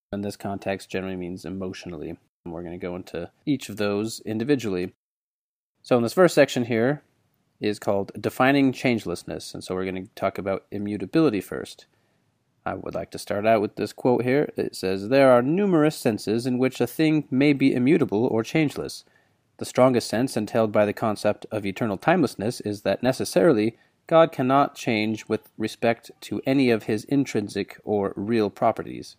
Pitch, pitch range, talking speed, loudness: 110 Hz, 100-130 Hz, 175 wpm, -24 LUFS